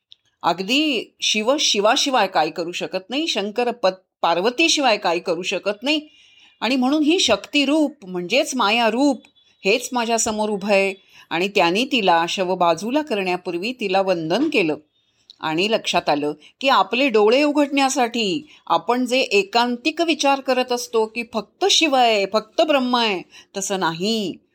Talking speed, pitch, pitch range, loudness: 140 wpm, 225 Hz, 185-270 Hz, -19 LUFS